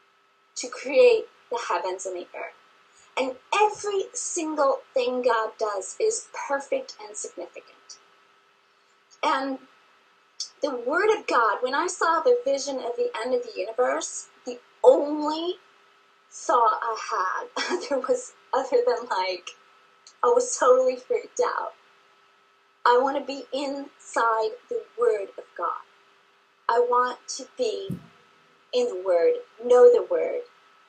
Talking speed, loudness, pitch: 130 wpm, -25 LUFS, 365 Hz